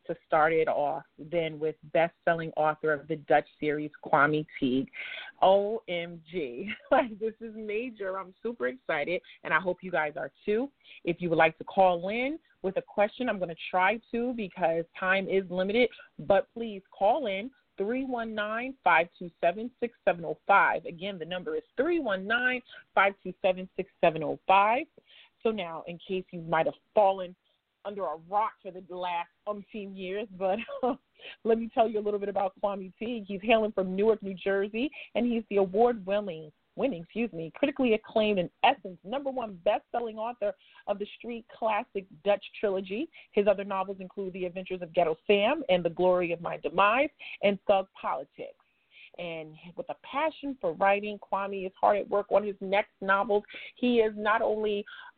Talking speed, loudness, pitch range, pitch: 165 wpm, -29 LUFS, 180-225 Hz, 200 Hz